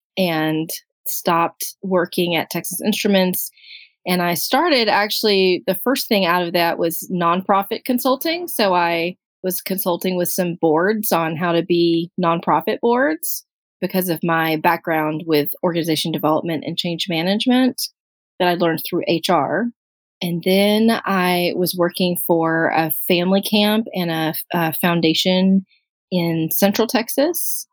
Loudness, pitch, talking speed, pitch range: -19 LUFS, 180 Hz, 135 wpm, 170-205 Hz